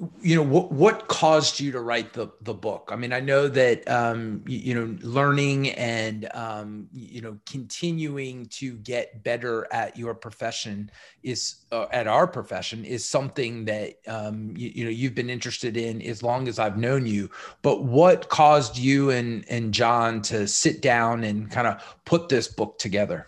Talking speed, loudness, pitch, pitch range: 185 wpm, -24 LUFS, 120 Hz, 110-135 Hz